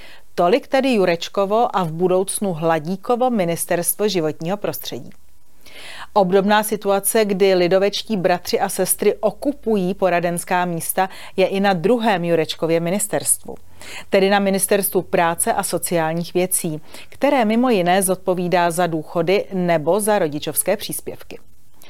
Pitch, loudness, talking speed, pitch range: 190 Hz, -19 LUFS, 120 wpm, 175-205 Hz